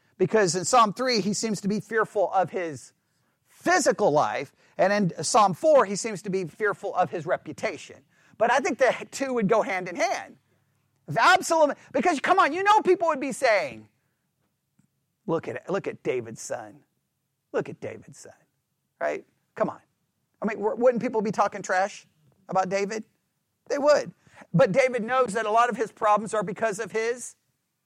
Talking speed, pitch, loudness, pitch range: 175 wpm, 215 Hz, -25 LUFS, 190-255 Hz